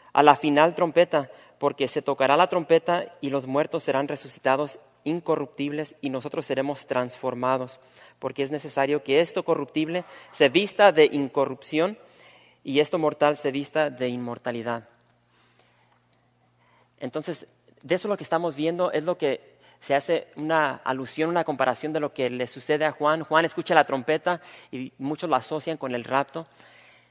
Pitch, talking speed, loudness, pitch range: 145 Hz, 155 wpm, -25 LUFS, 135-160 Hz